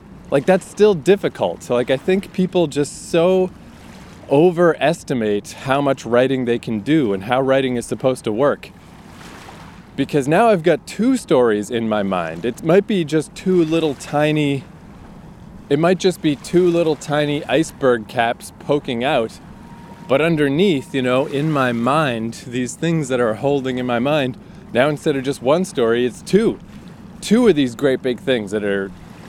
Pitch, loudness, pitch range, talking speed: 140 Hz, -18 LUFS, 125-170 Hz, 170 wpm